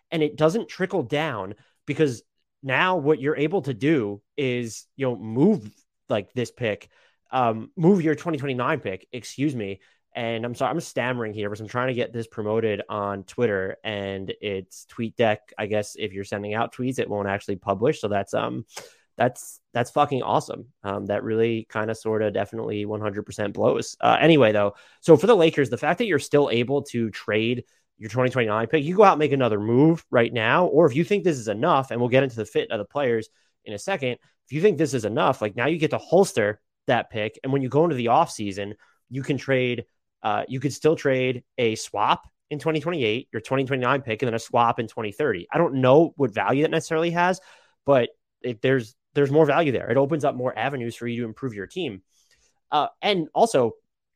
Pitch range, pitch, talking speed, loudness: 110-150 Hz, 125 Hz, 215 wpm, -23 LUFS